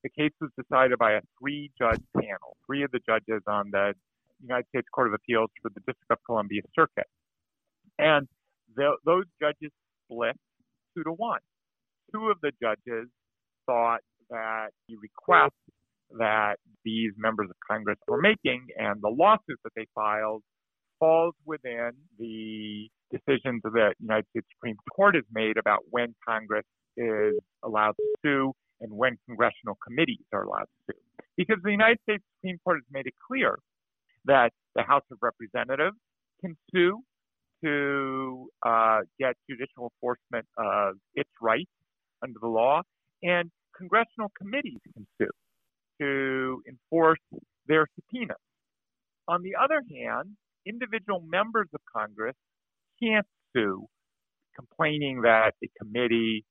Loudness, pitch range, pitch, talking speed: -27 LUFS, 110-165 Hz, 130 Hz, 140 wpm